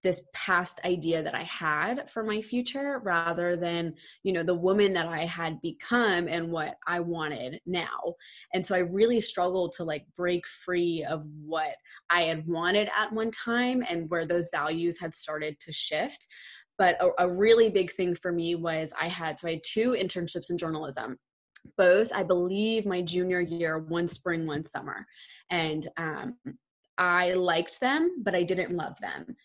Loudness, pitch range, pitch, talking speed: -28 LUFS, 165-190 Hz, 175 Hz, 175 wpm